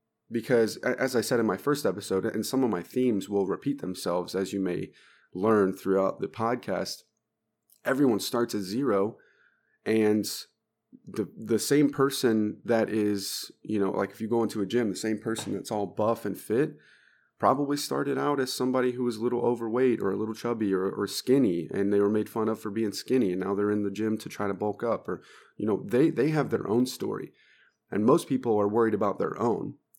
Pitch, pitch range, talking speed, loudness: 110 Hz, 100-125 Hz, 210 wpm, -28 LUFS